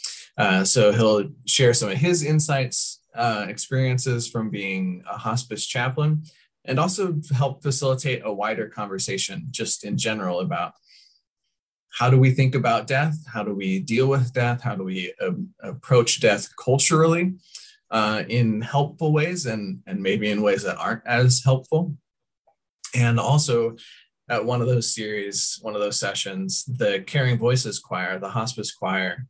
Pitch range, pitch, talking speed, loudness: 110-145 Hz, 125 Hz, 155 wpm, -22 LUFS